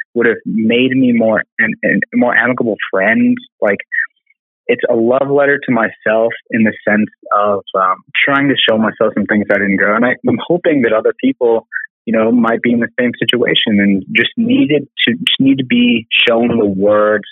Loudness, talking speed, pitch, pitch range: -13 LUFS, 200 wpm, 120 Hz, 105-140 Hz